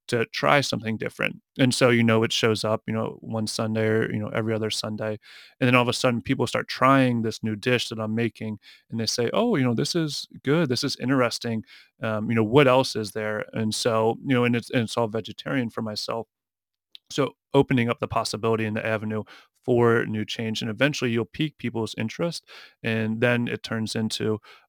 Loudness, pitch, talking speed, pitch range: -24 LUFS, 115 Hz, 215 wpm, 110-125 Hz